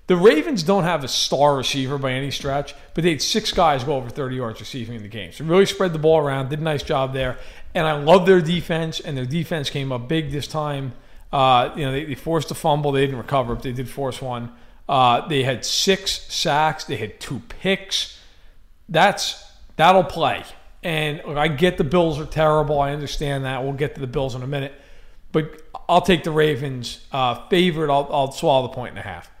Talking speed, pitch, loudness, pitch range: 220 wpm, 145 Hz, -21 LUFS, 135-165 Hz